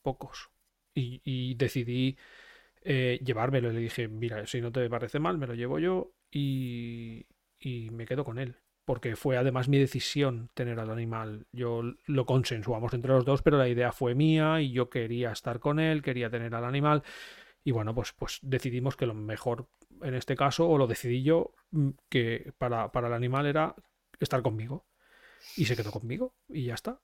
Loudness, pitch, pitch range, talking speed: -31 LUFS, 130 Hz, 120-140 Hz, 185 wpm